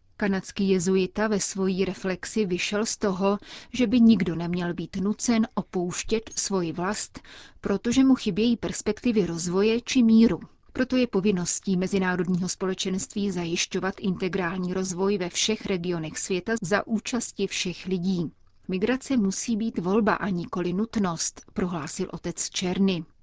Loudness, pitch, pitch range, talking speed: -26 LUFS, 195 Hz, 180-215 Hz, 130 wpm